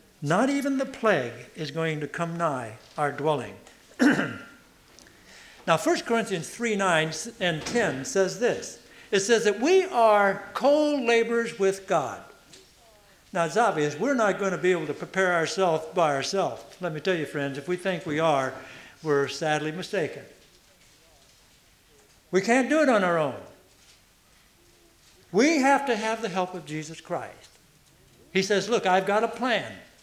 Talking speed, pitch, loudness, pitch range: 160 wpm, 185 Hz, -25 LUFS, 155-230 Hz